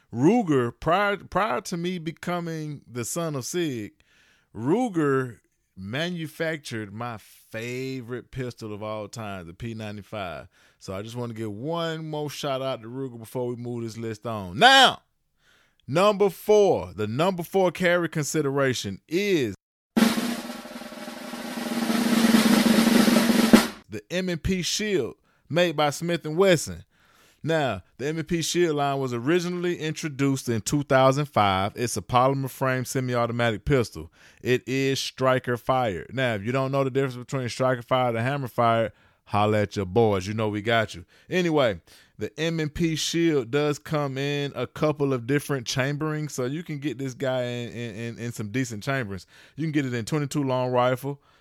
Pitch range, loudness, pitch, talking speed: 115-160 Hz, -25 LUFS, 135 Hz, 145 wpm